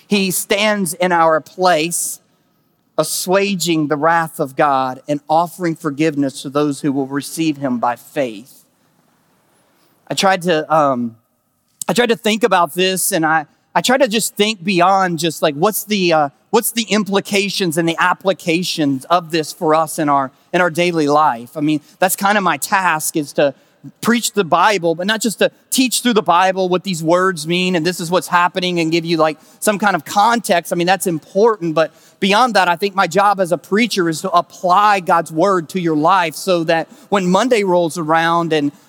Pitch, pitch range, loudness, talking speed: 175 Hz, 155-195 Hz, -16 LUFS, 195 wpm